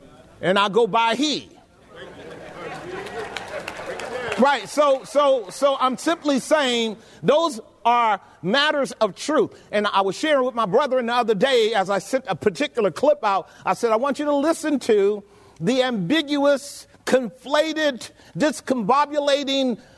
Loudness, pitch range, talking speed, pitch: -21 LUFS, 220-290 Hz, 140 wpm, 255 Hz